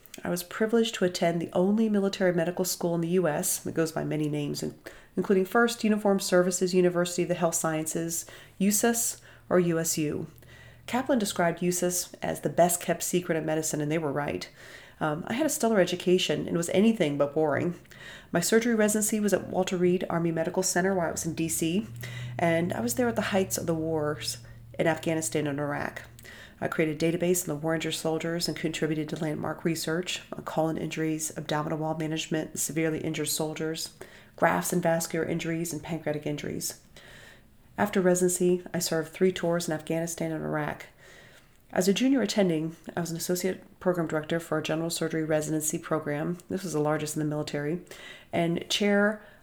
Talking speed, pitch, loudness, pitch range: 180 wpm, 165 Hz, -28 LUFS, 155-180 Hz